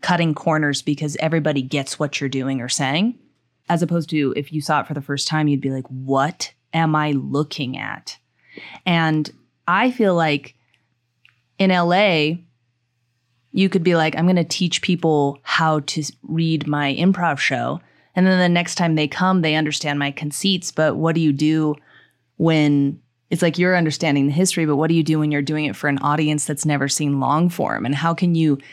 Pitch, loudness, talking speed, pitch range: 150 Hz, -19 LUFS, 195 wpm, 140-165 Hz